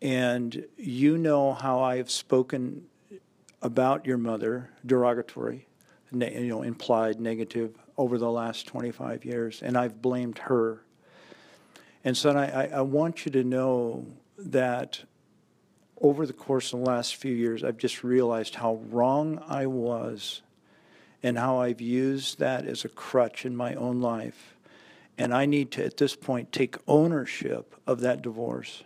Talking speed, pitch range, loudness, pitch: 150 wpm, 120-135 Hz, -28 LUFS, 125 Hz